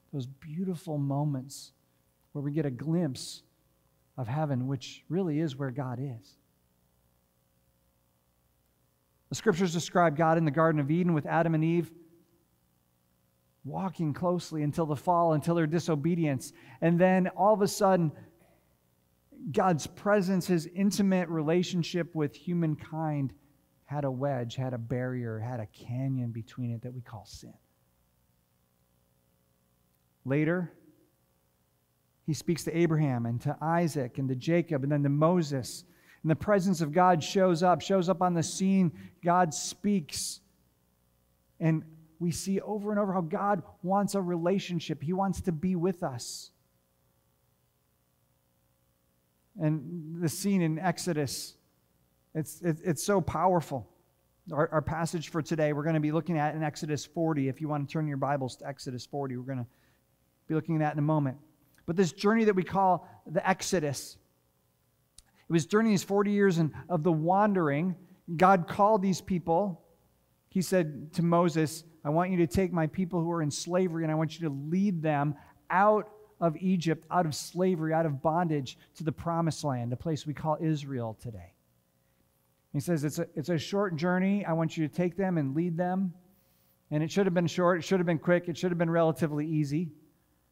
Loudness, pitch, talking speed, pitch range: -29 LUFS, 155 Hz, 165 wpm, 120-175 Hz